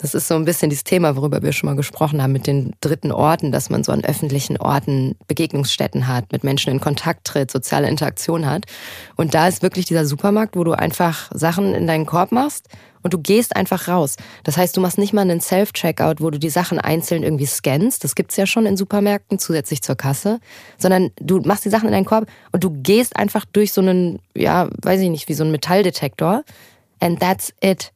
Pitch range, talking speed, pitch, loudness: 150-190 Hz, 220 wpm, 170 Hz, -18 LUFS